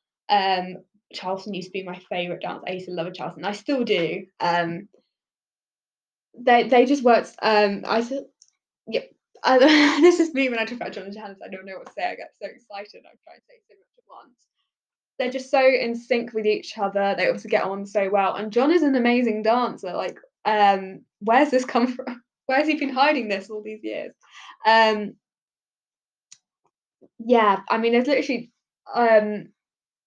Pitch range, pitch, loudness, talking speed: 200-260 Hz, 225 Hz, -22 LUFS, 190 wpm